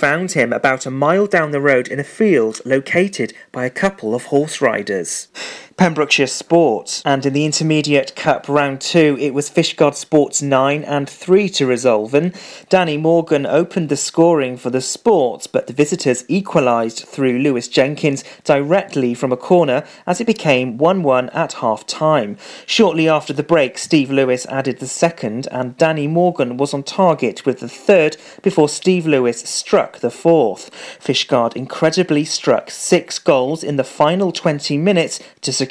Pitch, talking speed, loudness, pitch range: 145 Hz, 165 wpm, -16 LUFS, 135-165 Hz